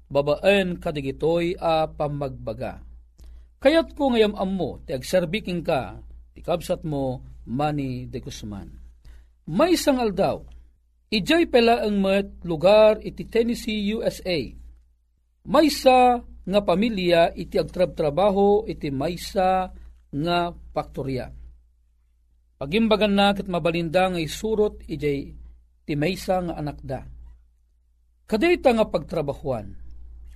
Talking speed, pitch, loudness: 105 wpm, 160 Hz, -23 LUFS